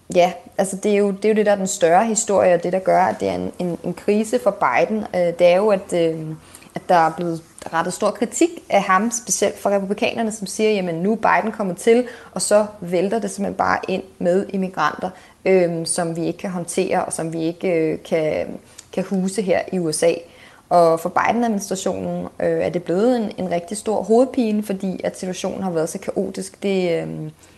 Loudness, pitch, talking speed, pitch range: -20 LUFS, 185 Hz, 215 wpm, 170-210 Hz